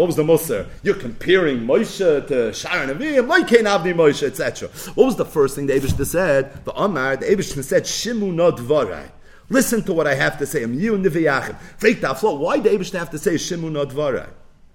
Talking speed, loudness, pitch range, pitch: 195 wpm, -19 LUFS, 150-210 Hz, 175 Hz